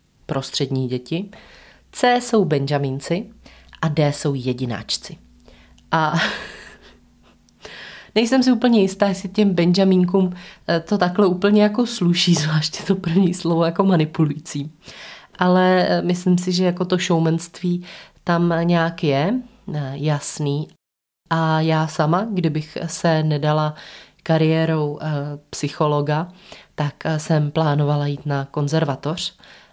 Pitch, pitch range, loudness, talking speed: 165 Hz, 150-185 Hz, -20 LUFS, 105 wpm